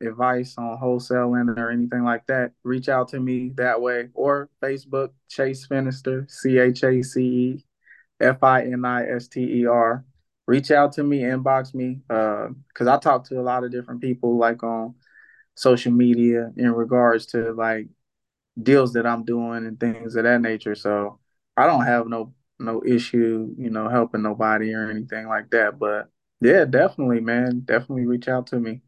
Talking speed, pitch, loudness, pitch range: 160 wpm, 120 Hz, -22 LUFS, 115-130 Hz